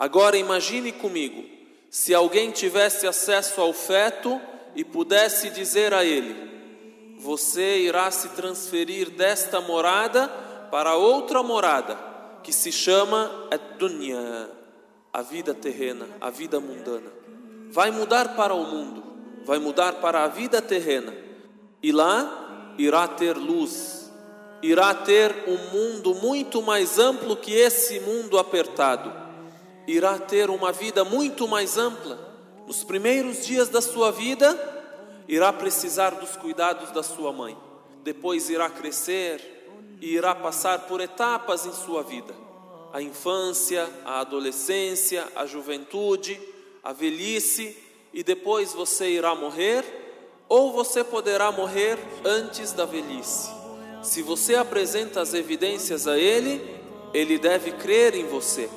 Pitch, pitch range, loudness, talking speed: 200 Hz, 175-240 Hz, -23 LUFS, 125 wpm